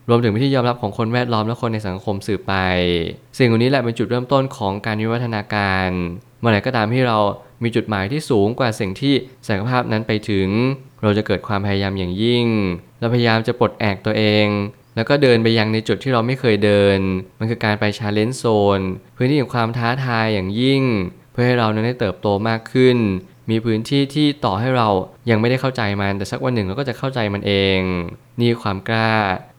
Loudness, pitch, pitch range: -19 LUFS, 110 Hz, 100-125 Hz